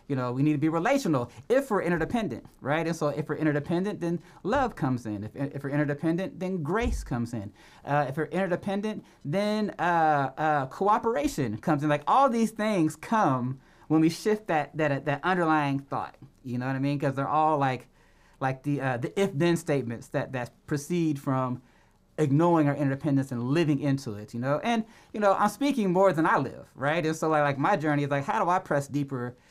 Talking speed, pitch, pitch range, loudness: 210 wpm, 150 Hz, 140-180 Hz, -27 LUFS